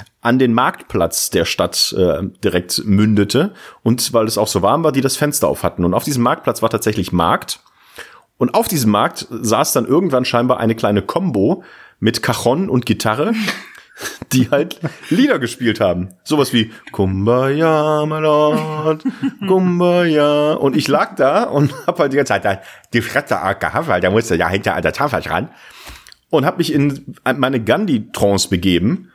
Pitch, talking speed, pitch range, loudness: 125 Hz, 165 wpm, 110-150 Hz, -16 LUFS